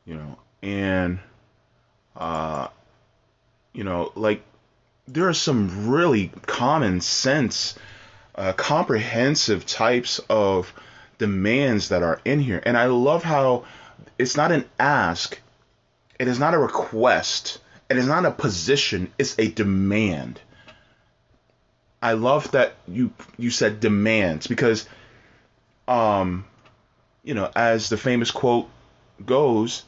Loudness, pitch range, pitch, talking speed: -22 LUFS, 100-125 Hz, 110 Hz, 120 wpm